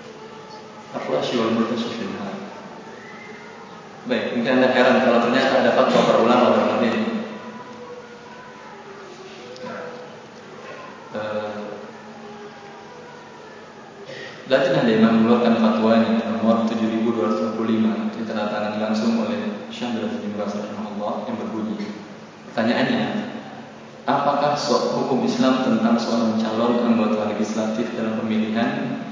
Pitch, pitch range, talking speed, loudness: 115 Hz, 110-125 Hz, 90 wpm, -21 LUFS